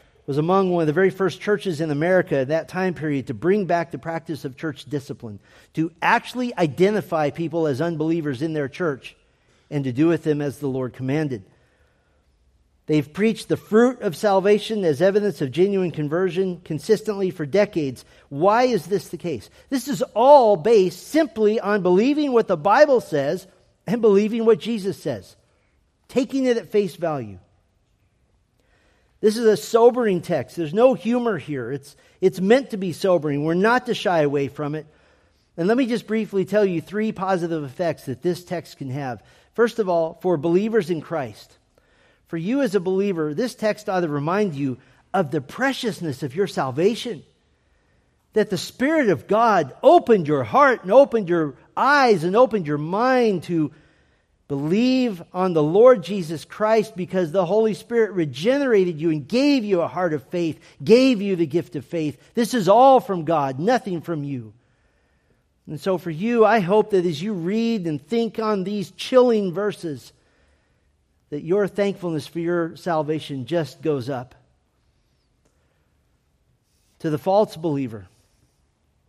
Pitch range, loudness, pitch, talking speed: 150-215 Hz, -21 LUFS, 175 Hz, 165 wpm